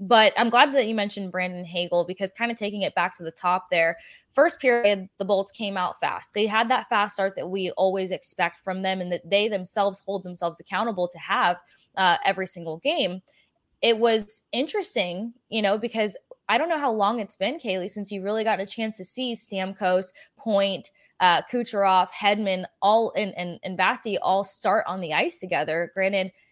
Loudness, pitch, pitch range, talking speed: -24 LUFS, 195 Hz, 185-220 Hz, 200 wpm